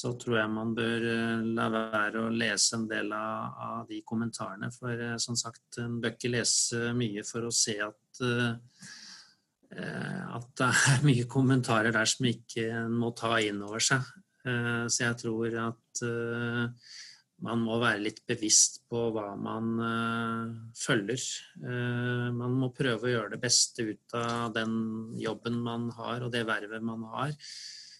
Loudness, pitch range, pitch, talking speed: -30 LUFS, 115-120 Hz, 115 Hz, 150 wpm